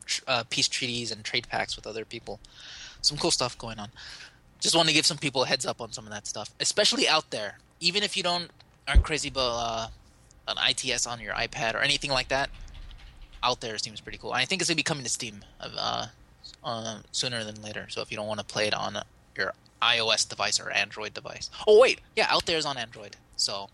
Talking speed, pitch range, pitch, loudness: 235 wpm, 110-145 Hz, 120 Hz, -26 LUFS